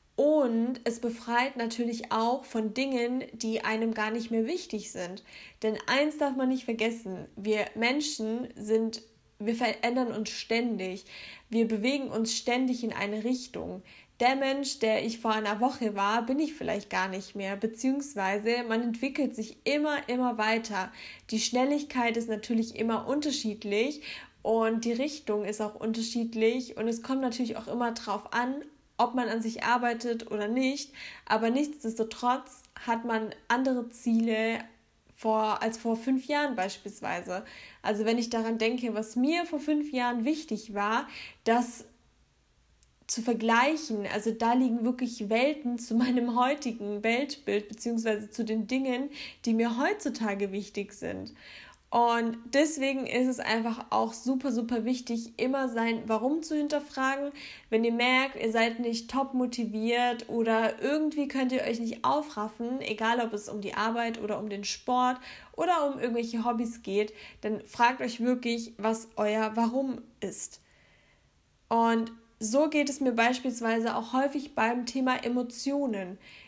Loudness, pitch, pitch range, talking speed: -30 LUFS, 235 Hz, 220-255 Hz, 150 wpm